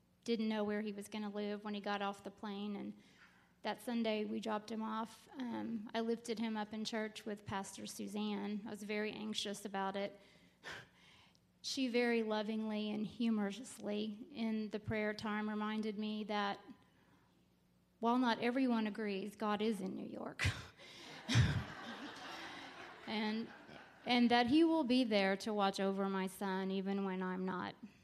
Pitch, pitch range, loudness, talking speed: 215 Hz, 205-225 Hz, -39 LUFS, 160 wpm